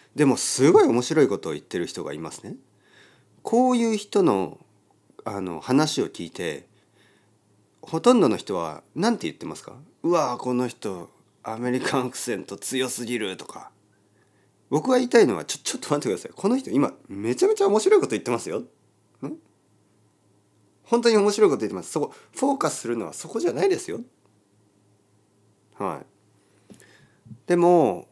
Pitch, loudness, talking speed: 125 Hz, -23 LUFS, 320 characters per minute